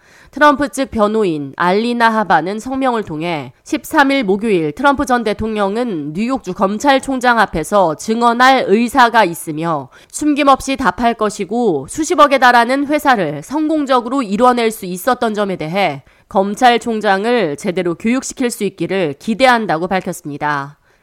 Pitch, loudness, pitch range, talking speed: 220 Hz, -15 LUFS, 185-260 Hz, 315 characters per minute